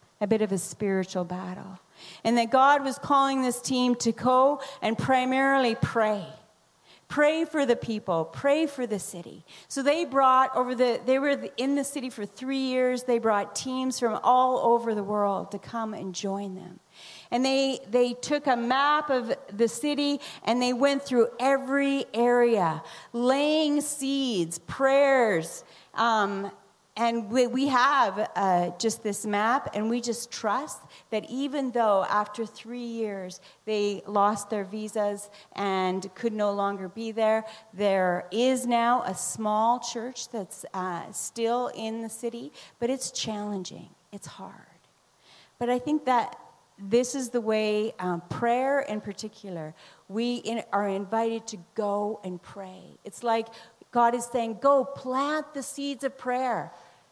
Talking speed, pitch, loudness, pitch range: 155 wpm, 230 Hz, -27 LUFS, 205-260 Hz